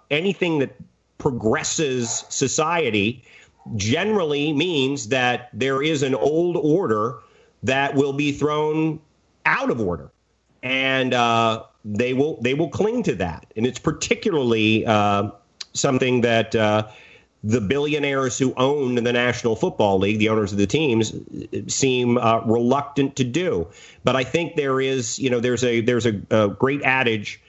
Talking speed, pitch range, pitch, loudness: 145 wpm, 115-140 Hz, 130 Hz, -21 LUFS